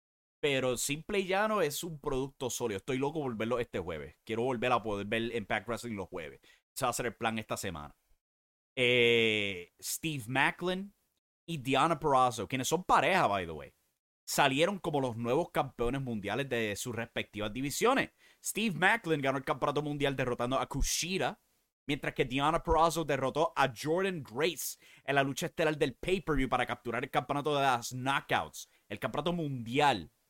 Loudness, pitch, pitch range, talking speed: -32 LUFS, 135 Hz, 120-160 Hz, 170 wpm